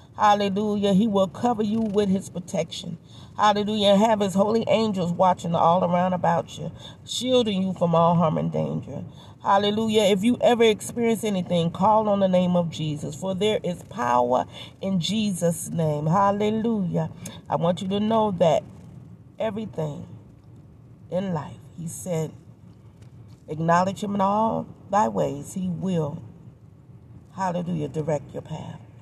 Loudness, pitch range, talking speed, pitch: -23 LUFS, 155-205 Hz, 145 wpm, 180 Hz